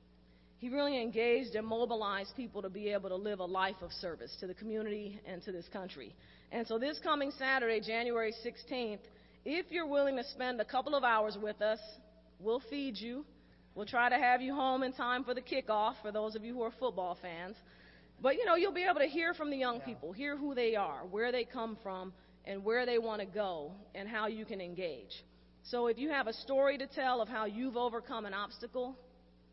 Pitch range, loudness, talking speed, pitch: 205-255 Hz, -36 LUFS, 215 wpm, 230 Hz